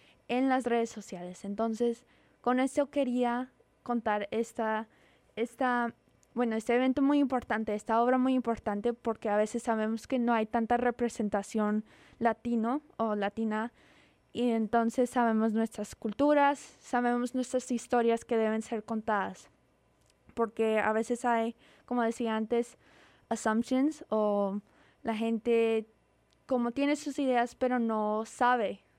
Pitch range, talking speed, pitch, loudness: 220-245 Hz, 130 wpm, 235 Hz, -31 LUFS